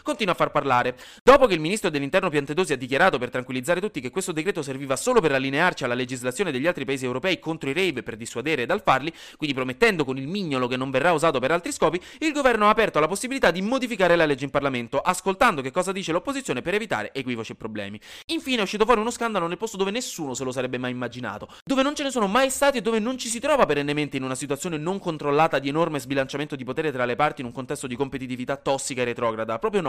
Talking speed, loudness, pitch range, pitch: 240 wpm, -24 LUFS, 130-205 Hz, 155 Hz